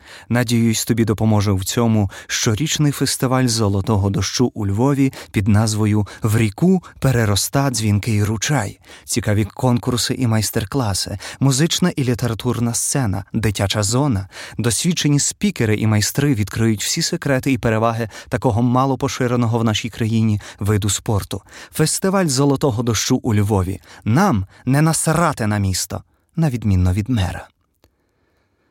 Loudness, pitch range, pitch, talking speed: -18 LUFS, 105-130 Hz, 115 Hz, 125 wpm